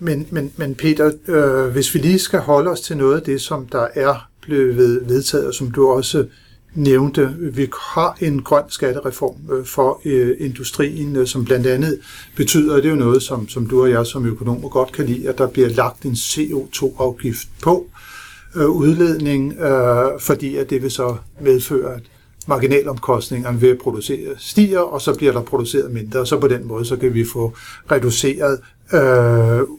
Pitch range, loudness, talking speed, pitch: 125-145 Hz, -17 LUFS, 180 wpm, 135 Hz